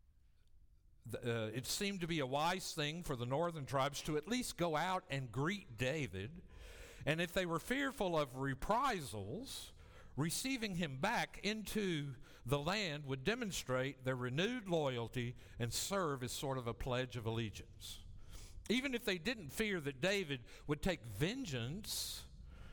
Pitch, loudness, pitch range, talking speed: 140 Hz, -40 LUFS, 115-185 Hz, 150 wpm